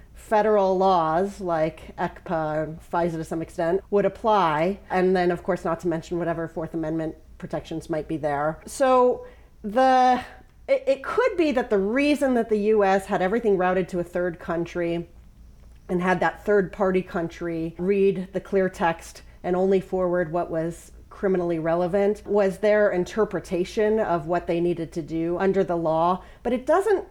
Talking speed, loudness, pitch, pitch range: 165 wpm, -24 LUFS, 180 Hz, 170-205 Hz